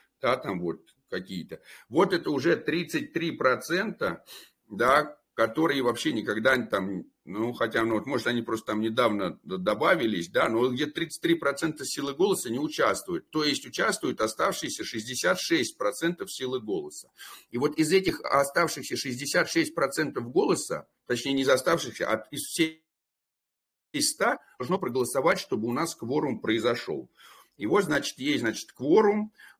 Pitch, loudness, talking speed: 150 Hz, -27 LUFS, 135 wpm